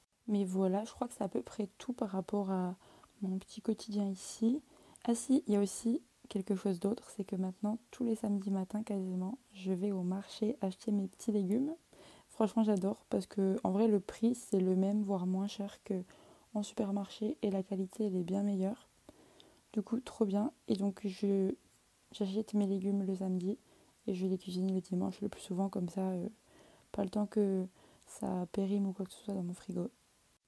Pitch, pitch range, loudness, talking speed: 200 Hz, 190-215 Hz, -36 LUFS, 205 wpm